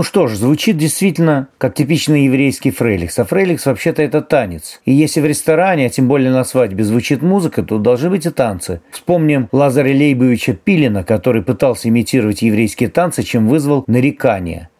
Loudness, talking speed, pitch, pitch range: -14 LUFS, 170 wpm, 135 Hz, 120-155 Hz